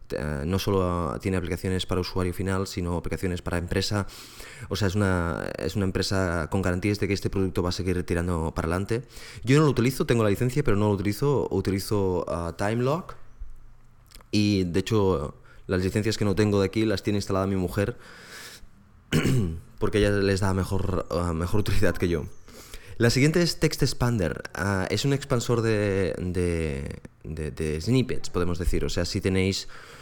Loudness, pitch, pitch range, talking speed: -26 LUFS, 95 Hz, 90-110 Hz, 180 wpm